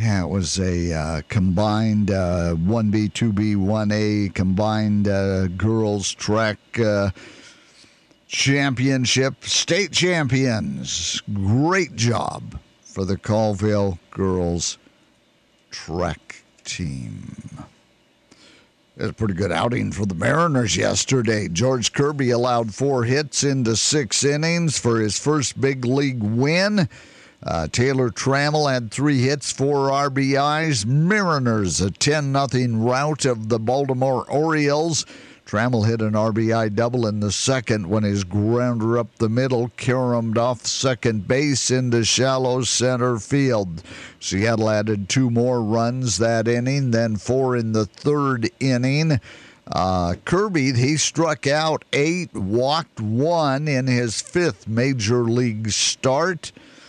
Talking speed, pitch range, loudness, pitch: 120 wpm, 105-135 Hz, -20 LUFS, 120 Hz